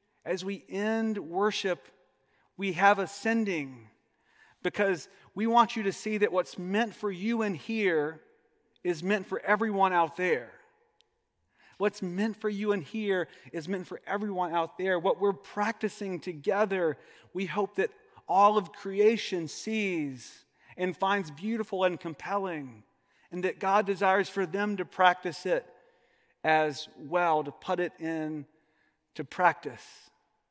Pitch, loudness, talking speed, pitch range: 195 Hz, -30 LUFS, 140 wpm, 175-210 Hz